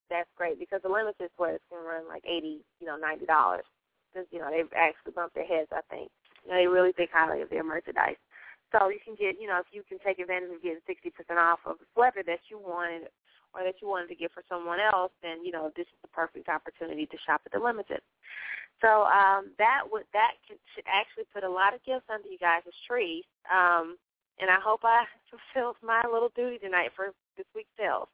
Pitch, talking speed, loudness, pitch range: 185 Hz, 230 wpm, -29 LUFS, 170-230 Hz